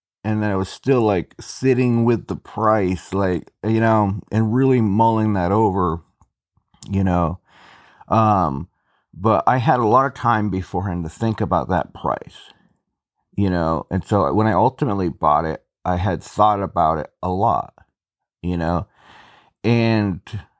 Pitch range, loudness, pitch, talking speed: 90-110 Hz, -20 LUFS, 100 Hz, 155 wpm